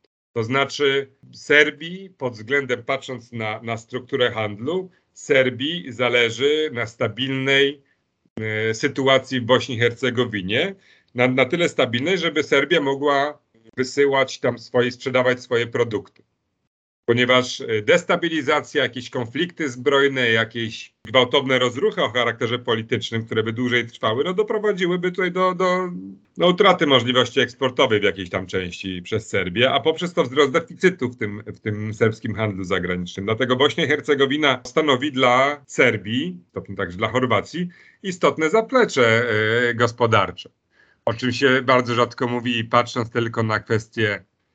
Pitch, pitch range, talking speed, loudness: 125 Hz, 115-145 Hz, 135 wpm, -20 LUFS